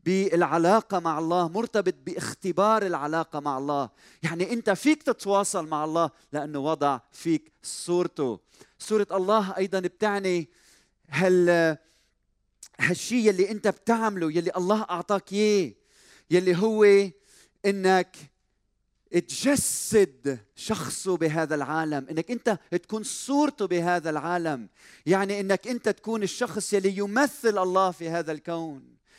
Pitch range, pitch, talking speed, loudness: 160-205 Hz, 180 Hz, 115 wpm, -26 LUFS